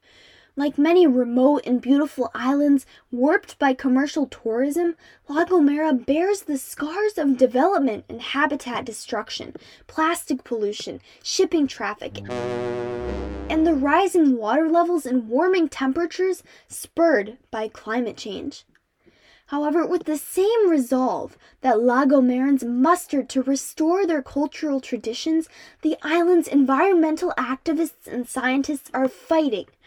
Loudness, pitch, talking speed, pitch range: -22 LUFS, 285 Hz, 115 wpm, 255-325 Hz